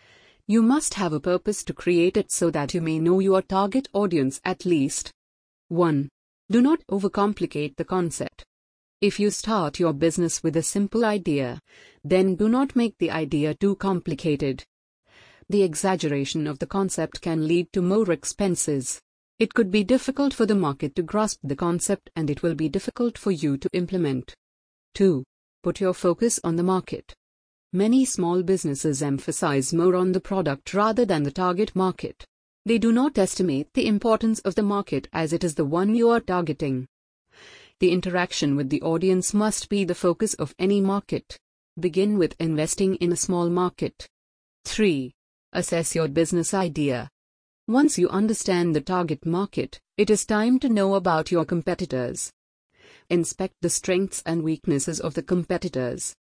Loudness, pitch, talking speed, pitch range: -24 LUFS, 180 Hz, 165 wpm, 155-200 Hz